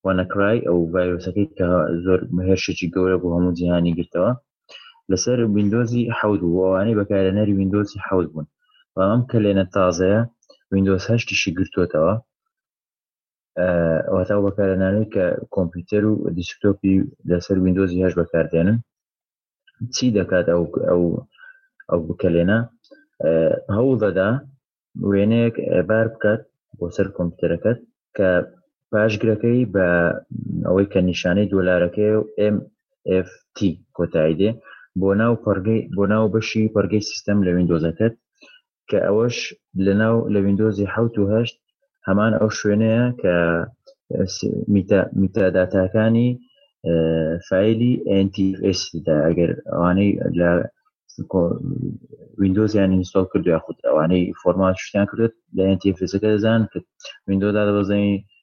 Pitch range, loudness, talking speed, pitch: 90-110 Hz, -20 LUFS, 110 wpm, 100 Hz